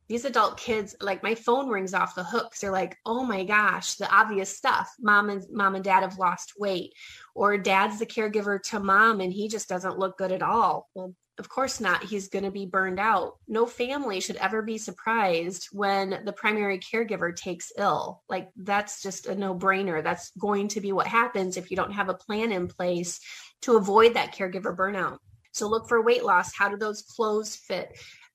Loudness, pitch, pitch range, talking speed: -26 LUFS, 200 Hz, 190-220 Hz, 205 wpm